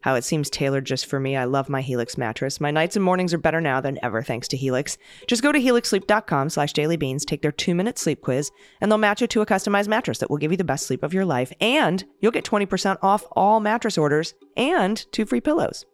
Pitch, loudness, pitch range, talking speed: 165 Hz, -22 LUFS, 140-210 Hz, 250 wpm